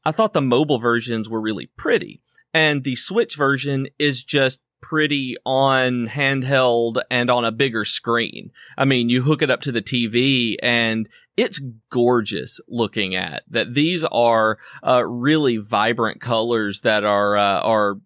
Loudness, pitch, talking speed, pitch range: -19 LUFS, 125 Hz, 155 wpm, 115-140 Hz